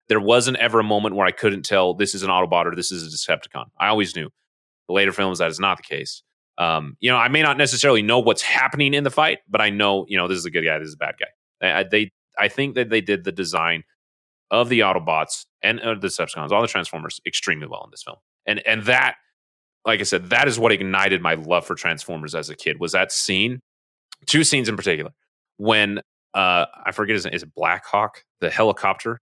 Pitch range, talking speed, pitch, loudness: 95-120 Hz, 240 wpm, 105 Hz, -20 LUFS